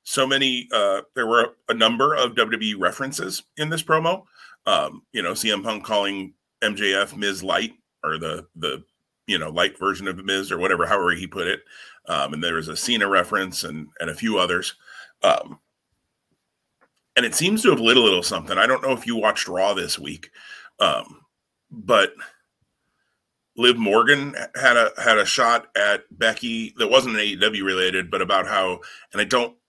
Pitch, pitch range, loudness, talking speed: 110 Hz, 95-130 Hz, -21 LUFS, 180 wpm